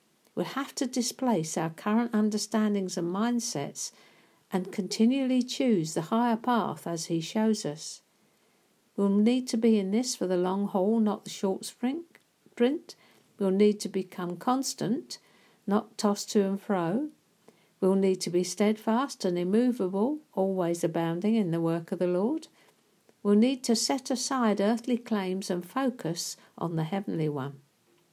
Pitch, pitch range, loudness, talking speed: 205 Hz, 185-235 Hz, -29 LUFS, 150 wpm